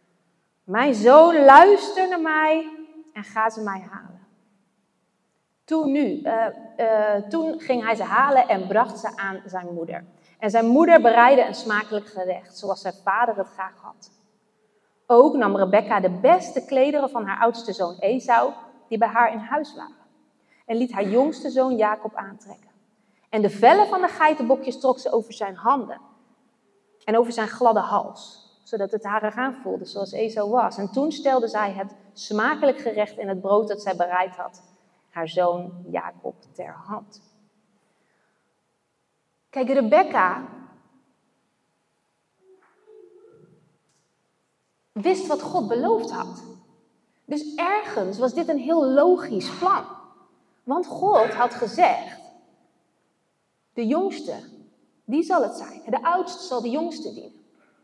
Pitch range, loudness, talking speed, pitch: 210-295 Hz, -21 LUFS, 140 wpm, 230 Hz